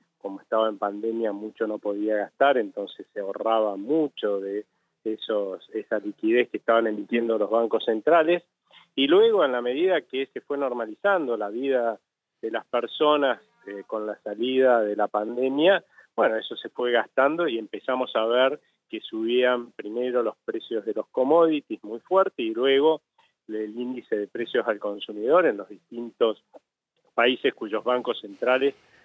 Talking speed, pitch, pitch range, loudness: 160 wpm, 120 Hz, 110-140 Hz, -25 LUFS